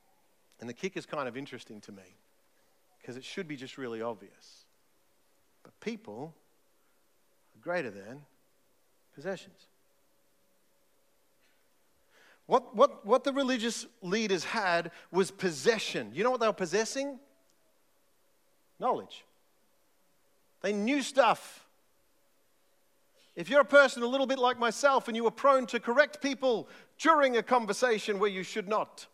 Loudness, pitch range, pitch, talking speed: -29 LUFS, 170-255 Hz, 215 Hz, 130 wpm